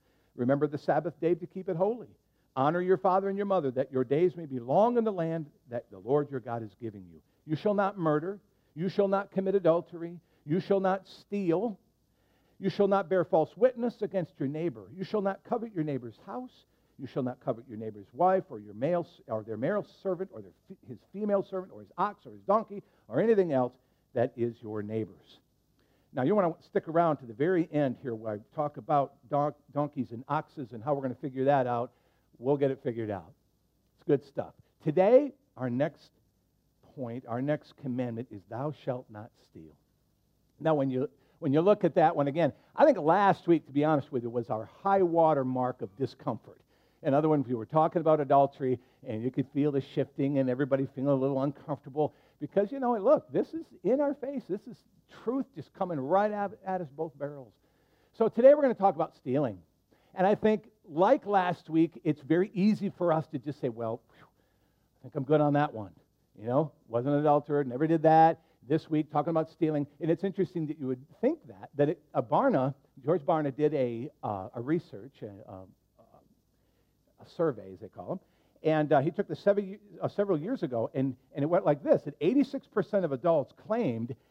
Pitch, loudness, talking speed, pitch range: 150 Hz, -30 LUFS, 210 wpm, 130-185 Hz